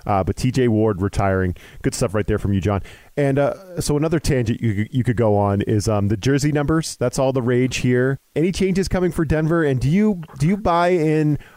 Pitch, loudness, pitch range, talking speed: 130 Hz, -20 LUFS, 110-155 Hz, 230 wpm